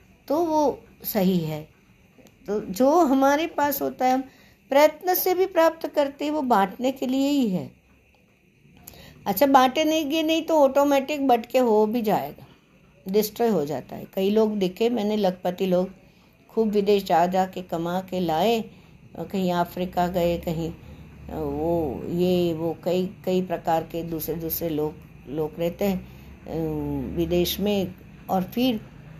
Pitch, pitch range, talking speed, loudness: 190 Hz, 170-255 Hz, 145 wpm, -24 LUFS